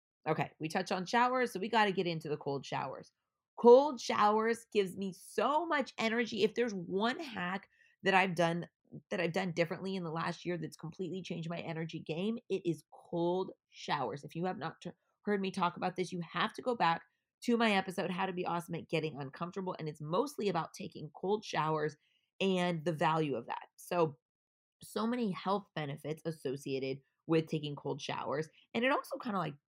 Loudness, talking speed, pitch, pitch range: -35 LUFS, 200 wpm, 180 Hz, 160-205 Hz